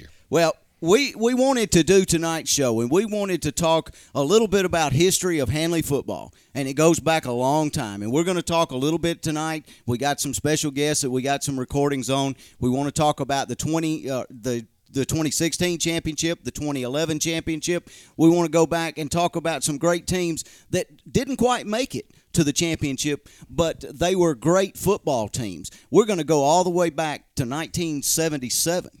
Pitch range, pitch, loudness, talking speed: 140-170 Hz, 160 Hz, -22 LUFS, 205 wpm